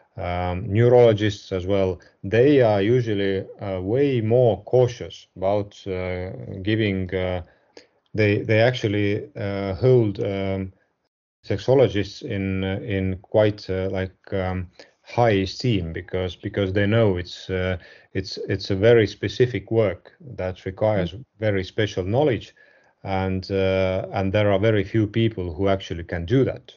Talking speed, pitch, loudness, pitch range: 130 wpm, 100 Hz, -22 LUFS, 95-110 Hz